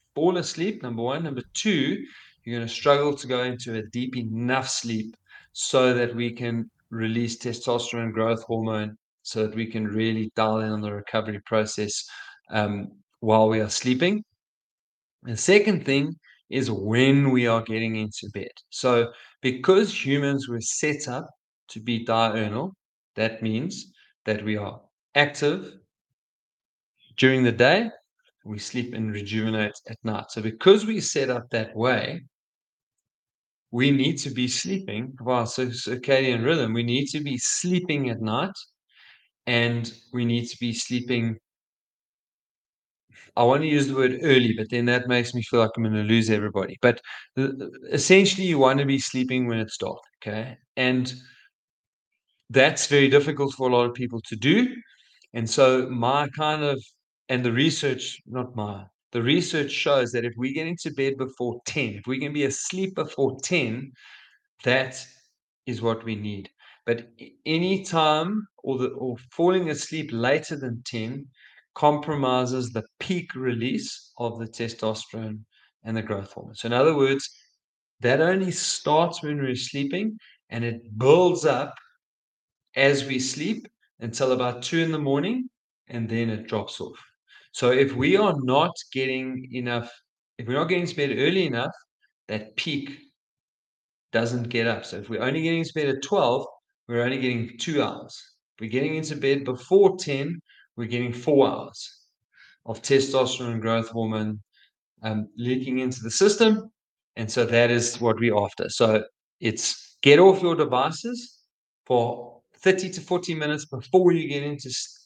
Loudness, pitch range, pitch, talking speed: -24 LUFS, 115-145 Hz, 125 Hz, 160 wpm